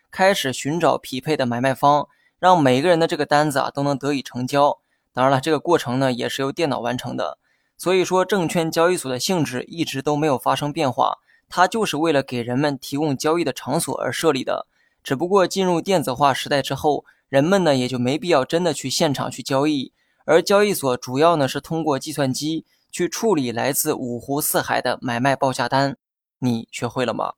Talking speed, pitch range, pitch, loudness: 310 characters per minute, 130-165 Hz, 145 Hz, -21 LUFS